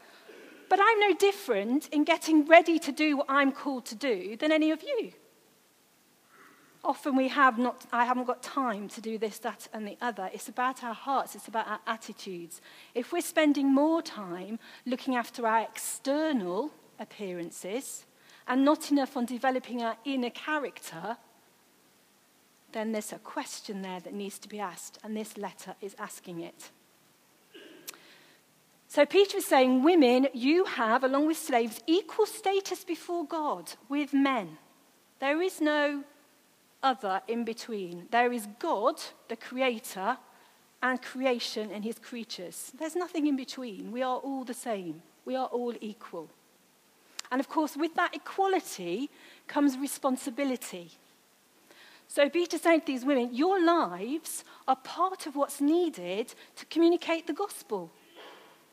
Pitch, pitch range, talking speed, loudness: 265 Hz, 230-315 Hz, 150 wpm, -29 LUFS